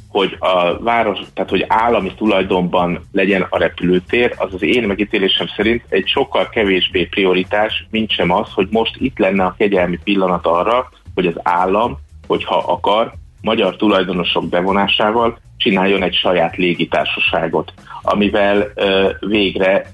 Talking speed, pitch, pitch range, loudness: 135 wpm, 95 Hz, 90-105 Hz, -16 LUFS